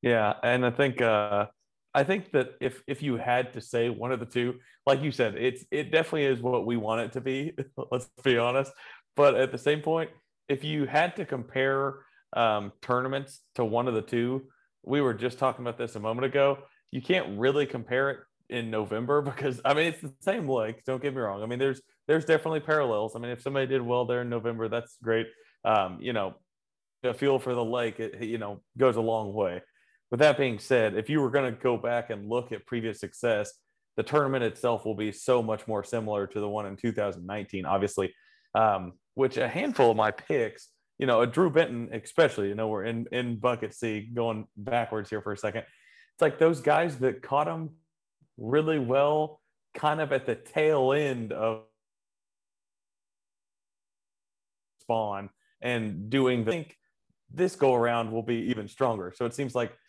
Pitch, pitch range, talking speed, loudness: 125 Hz, 110-140 Hz, 200 wpm, -28 LUFS